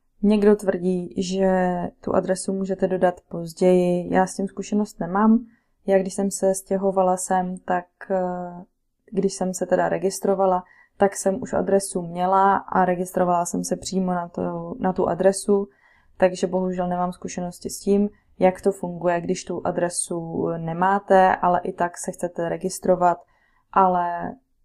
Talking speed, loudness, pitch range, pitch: 145 wpm, -22 LUFS, 180-195 Hz, 185 Hz